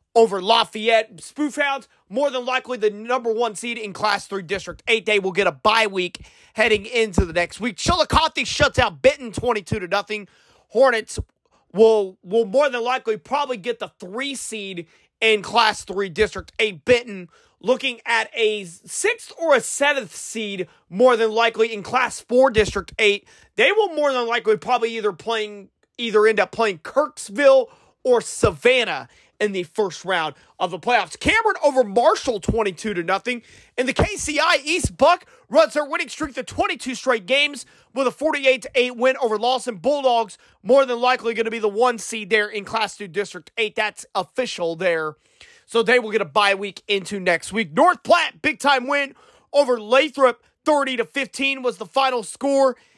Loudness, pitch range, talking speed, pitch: -20 LUFS, 210-270 Hz, 180 wpm, 230 Hz